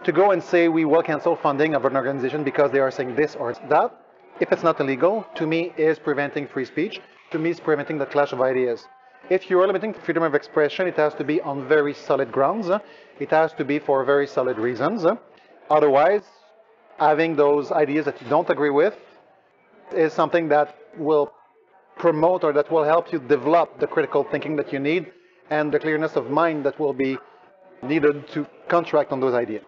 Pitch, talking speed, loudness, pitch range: 150 Hz, 200 wpm, -22 LUFS, 145-170 Hz